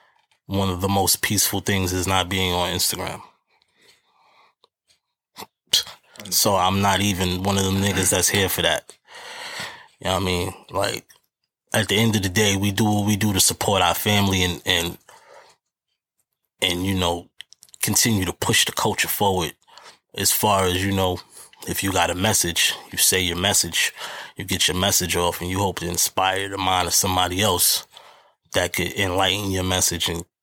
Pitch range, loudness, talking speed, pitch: 90-100 Hz, -20 LUFS, 175 wpm, 95 Hz